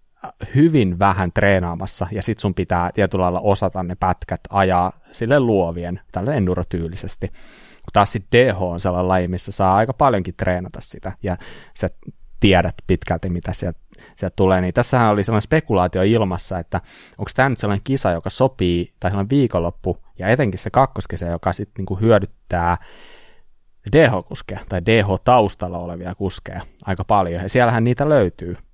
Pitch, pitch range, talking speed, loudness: 95 Hz, 90-110 Hz, 150 wpm, -19 LUFS